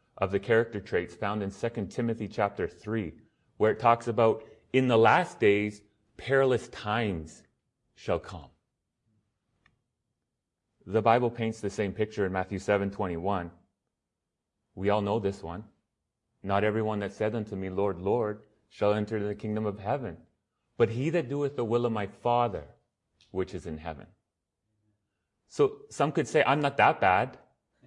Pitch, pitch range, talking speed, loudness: 105 Hz, 100-115 Hz, 155 wpm, -29 LUFS